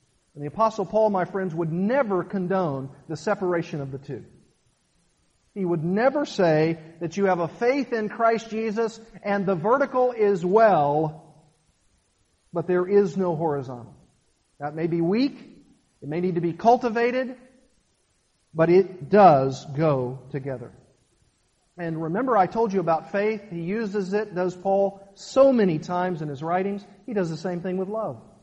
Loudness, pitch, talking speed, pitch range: -24 LUFS, 185 Hz, 160 wpm, 160-215 Hz